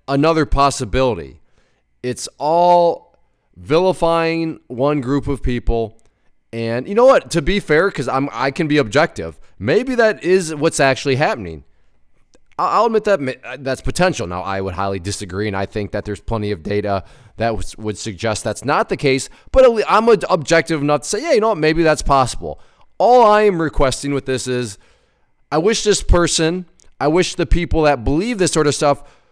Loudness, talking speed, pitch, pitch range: -17 LUFS, 175 wpm, 140 Hz, 115-170 Hz